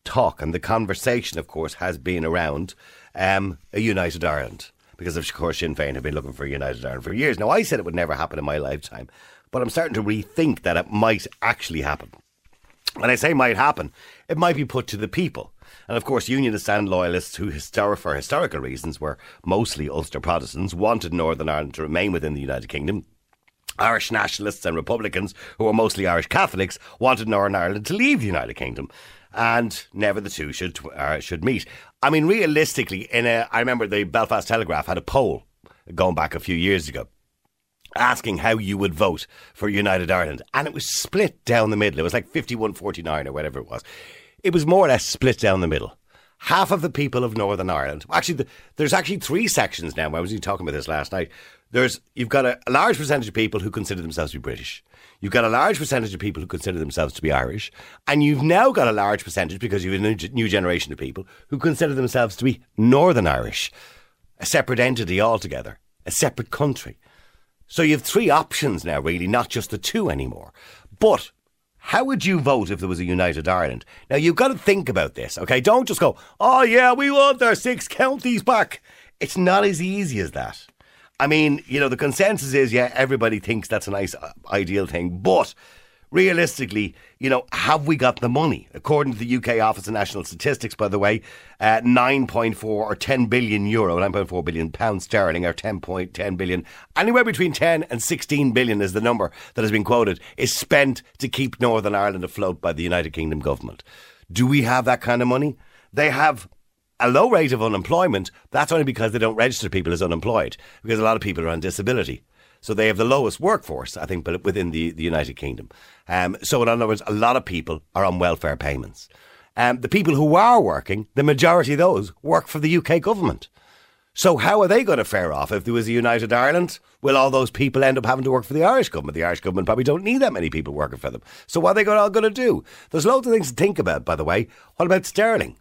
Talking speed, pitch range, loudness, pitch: 220 wpm, 90-135 Hz, -21 LUFS, 110 Hz